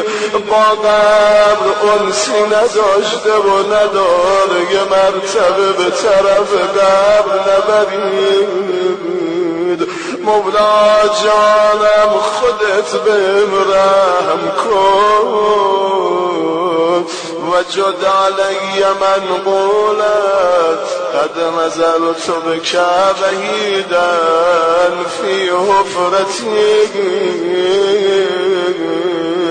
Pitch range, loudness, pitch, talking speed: 185-210 Hz, -12 LUFS, 195 Hz, 65 wpm